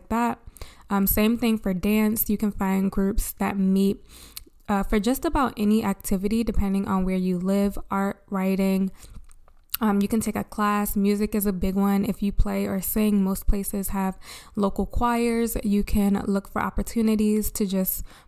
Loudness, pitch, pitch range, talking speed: -24 LUFS, 200 Hz, 195-215 Hz, 175 wpm